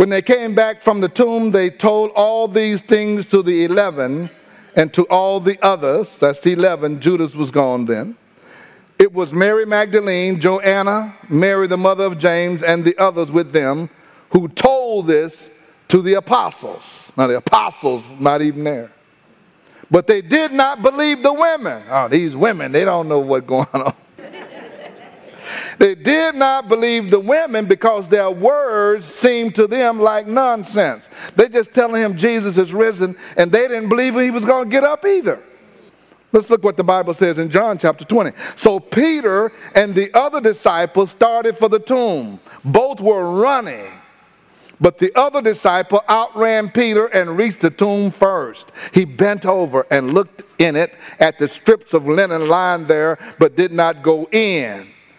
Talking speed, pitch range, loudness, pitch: 170 wpm, 170-225 Hz, -15 LUFS, 195 Hz